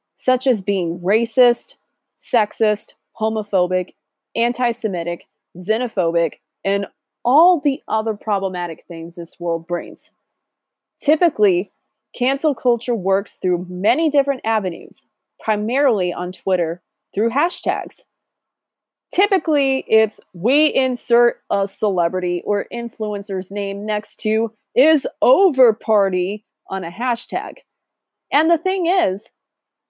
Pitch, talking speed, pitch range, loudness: 220 Hz, 105 wpm, 190-260 Hz, -19 LUFS